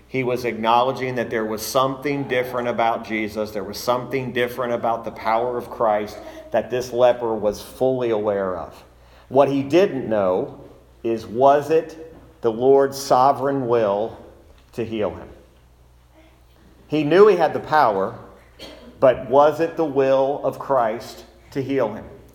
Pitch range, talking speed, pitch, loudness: 110-135 Hz, 150 wpm, 120 Hz, -20 LUFS